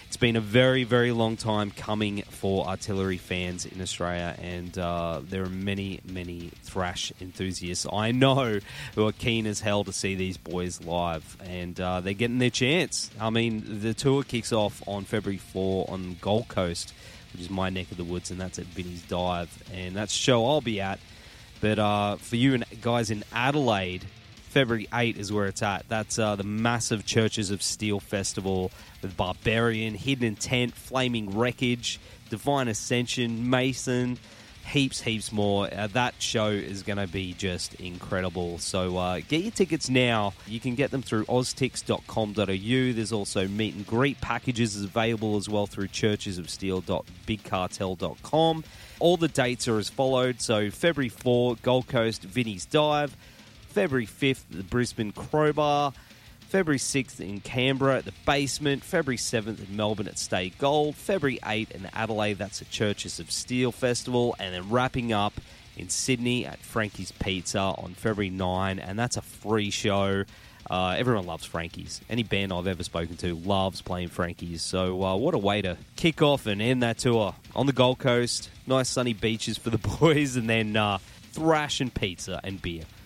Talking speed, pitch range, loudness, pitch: 170 wpm, 95-120 Hz, -27 LUFS, 105 Hz